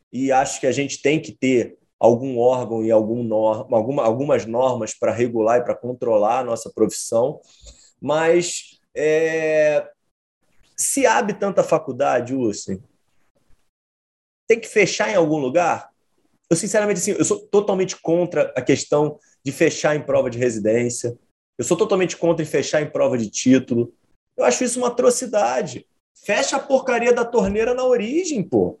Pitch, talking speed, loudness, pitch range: 155 Hz, 150 wpm, -20 LUFS, 125-205 Hz